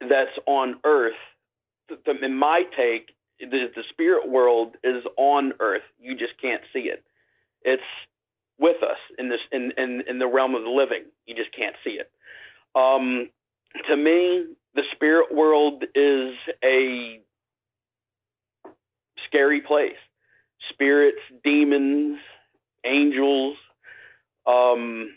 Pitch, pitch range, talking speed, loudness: 140 Hz, 125-155 Hz, 125 wpm, -22 LUFS